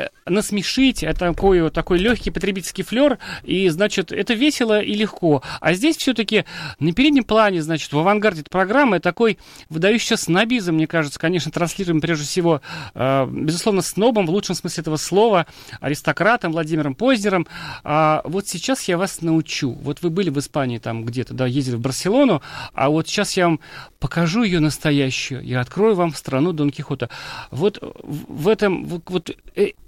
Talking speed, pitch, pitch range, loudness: 160 wpm, 175 Hz, 150-205 Hz, -19 LUFS